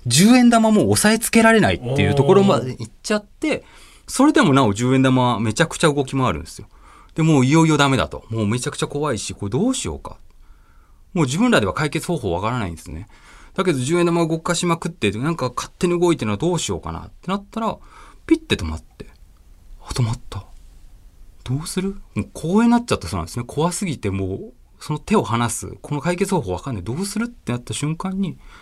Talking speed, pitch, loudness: 430 characters per minute, 145 Hz, -19 LUFS